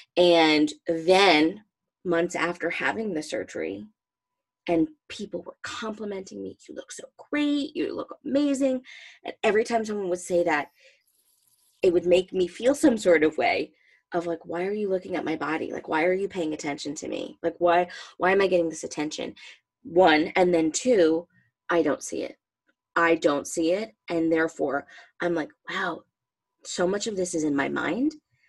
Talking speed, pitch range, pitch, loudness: 180 wpm, 165-215 Hz, 175 Hz, -25 LUFS